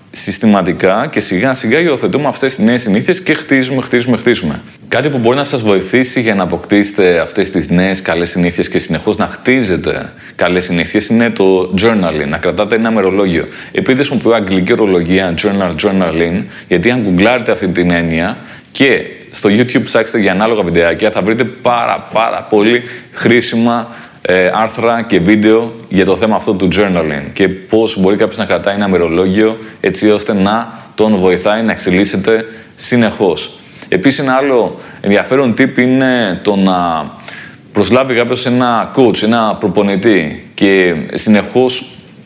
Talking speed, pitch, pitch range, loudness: 150 wpm, 110 Hz, 95-120 Hz, -12 LUFS